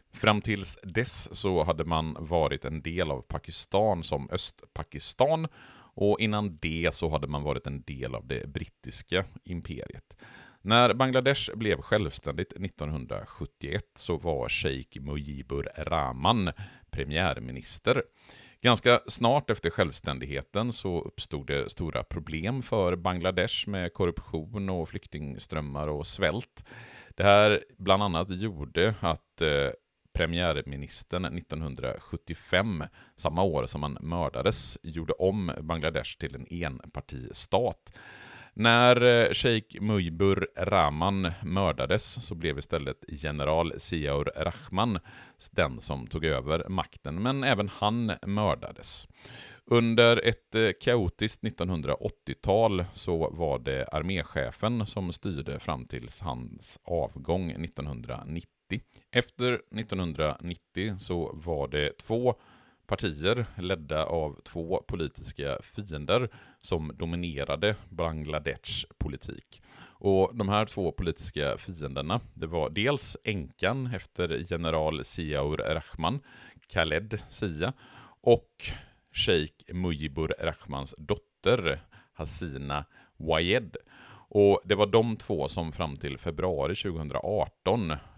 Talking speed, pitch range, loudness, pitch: 105 wpm, 75-105 Hz, -29 LUFS, 90 Hz